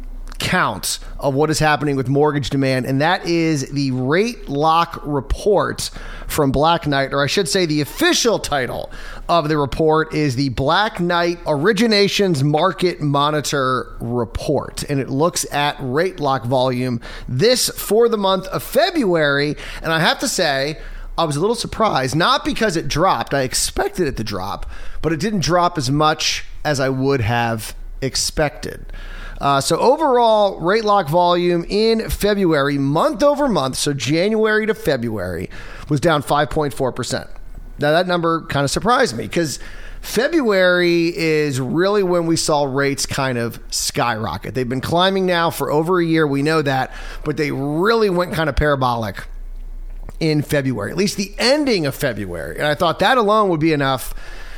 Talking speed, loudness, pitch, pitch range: 165 wpm, -18 LUFS, 150 Hz, 135-180 Hz